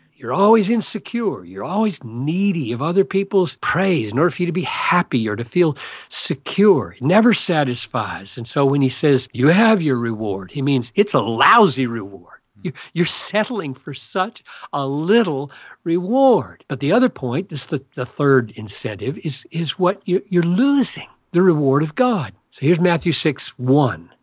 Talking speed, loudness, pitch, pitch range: 170 wpm, -19 LUFS, 155 Hz, 130-190 Hz